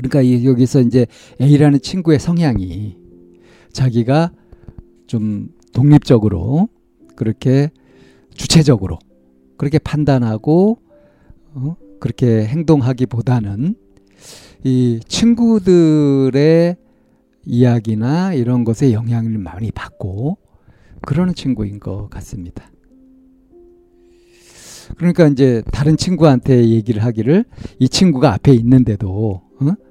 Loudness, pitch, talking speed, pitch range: -15 LUFS, 130 Hz, 225 characters per minute, 110-160 Hz